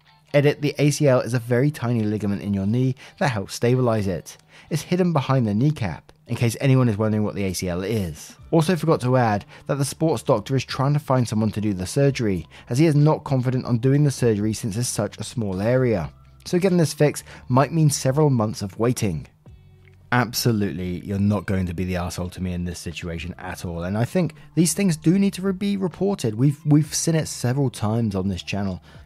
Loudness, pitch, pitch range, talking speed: -22 LUFS, 120 Hz, 100-145 Hz, 215 wpm